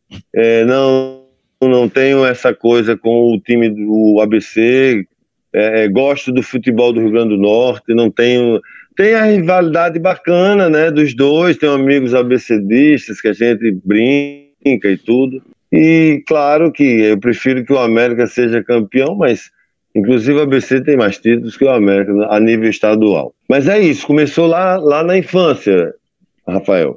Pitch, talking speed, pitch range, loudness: 125 Hz, 155 wpm, 115-145 Hz, -12 LUFS